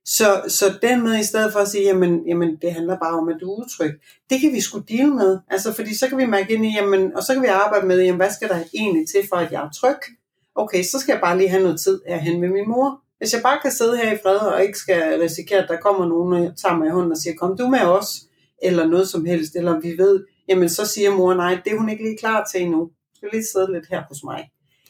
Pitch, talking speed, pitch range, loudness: 195 Hz, 290 wpm, 175-220 Hz, -19 LUFS